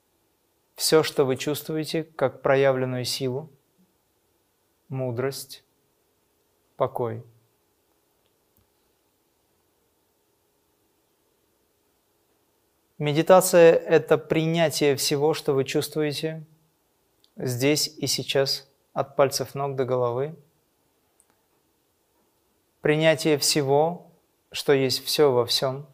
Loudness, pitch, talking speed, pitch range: -23 LUFS, 145 Hz, 70 wpm, 135-155 Hz